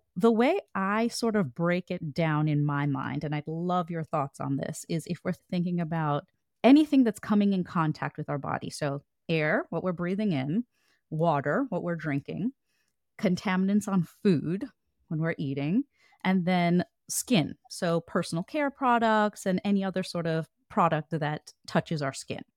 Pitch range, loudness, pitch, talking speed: 155-200 Hz, -28 LUFS, 175 Hz, 170 wpm